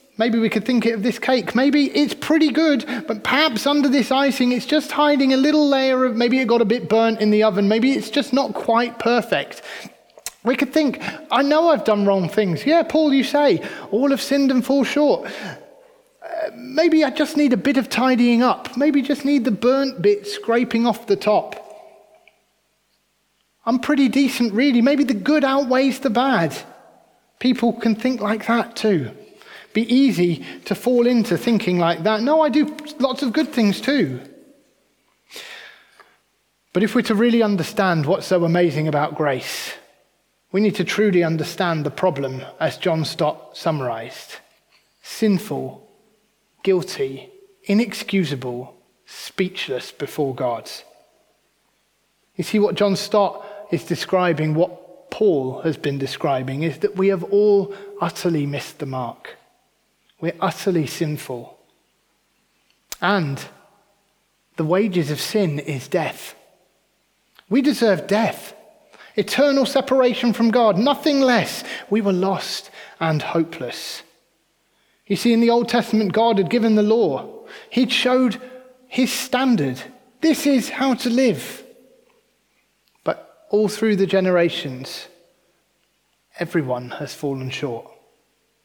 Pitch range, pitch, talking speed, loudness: 190-270 Hz, 230 Hz, 145 wpm, -19 LUFS